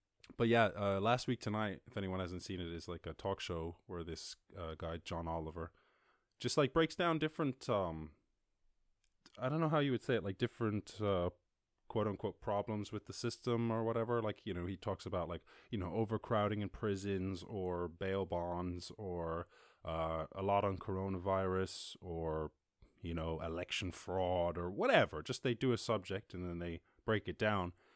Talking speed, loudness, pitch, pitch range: 185 wpm, -39 LUFS, 95 Hz, 85-110 Hz